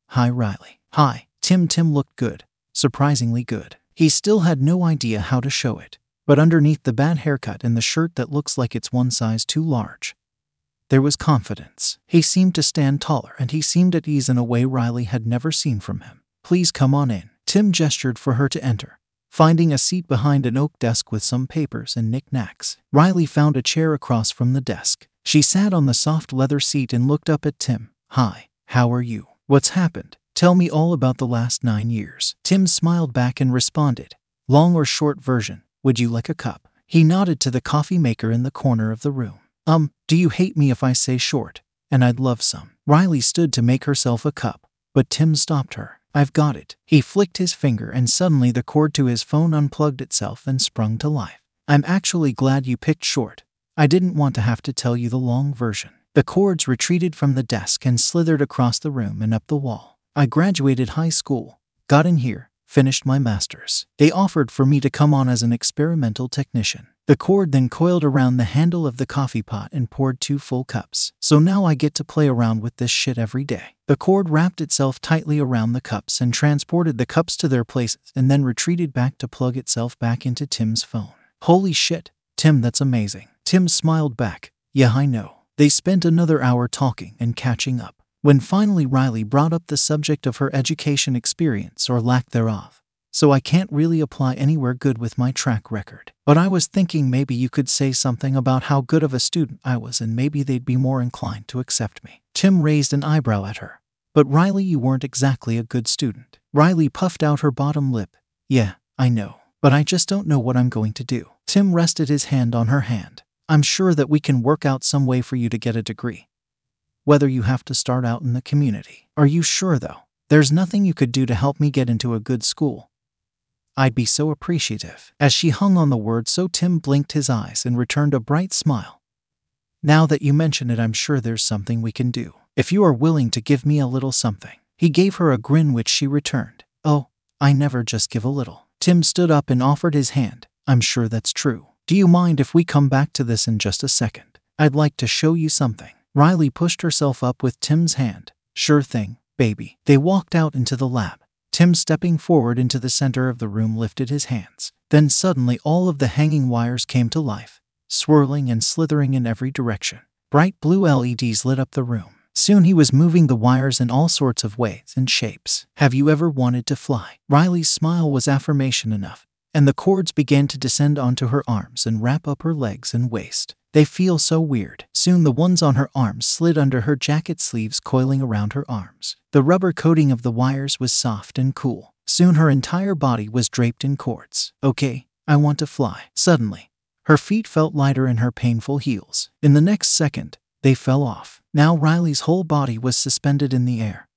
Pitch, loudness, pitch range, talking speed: 135 Hz, -19 LUFS, 120-155 Hz, 210 wpm